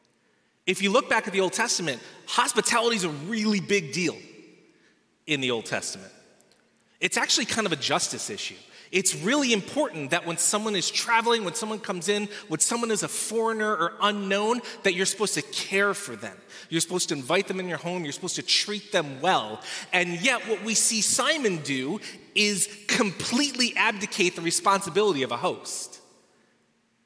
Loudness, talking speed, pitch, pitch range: -25 LUFS, 175 wpm, 200 Hz, 175-220 Hz